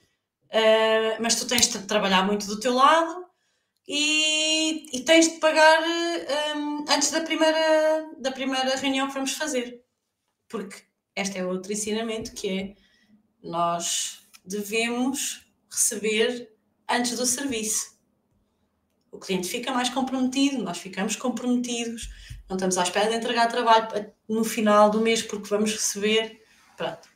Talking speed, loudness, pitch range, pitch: 135 wpm, -23 LUFS, 215-275 Hz, 235 Hz